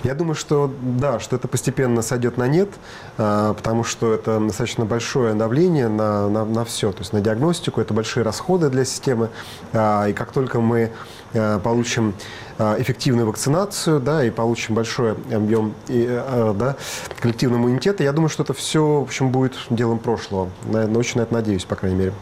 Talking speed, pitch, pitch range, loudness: 165 wpm, 115 Hz, 110-130 Hz, -20 LUFS